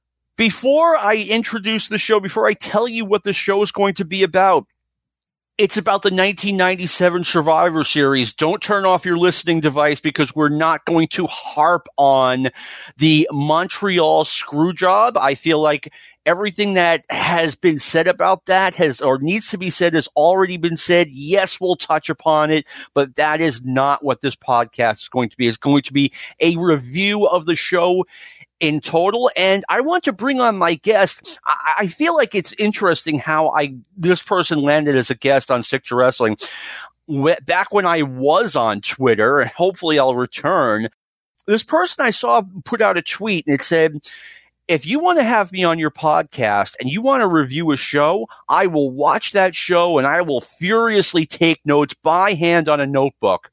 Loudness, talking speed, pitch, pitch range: -17 LUFS, 185 wpm, 165 Hz, 150-195 Hz